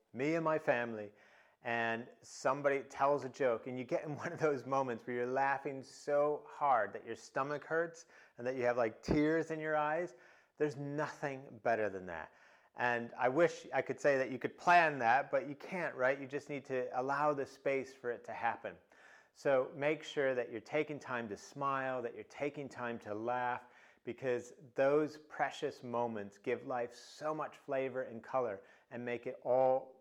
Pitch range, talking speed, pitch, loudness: 120-150 Hz, 190 wpm, 135 Hz, -37 LUFS